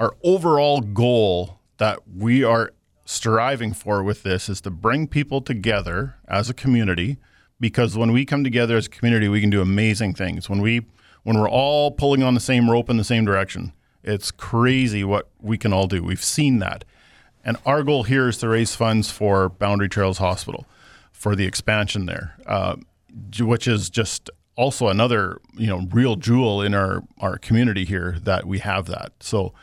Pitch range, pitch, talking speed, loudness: 95-120 Hz, 110 Hz, 185 wpm, -21 LUFS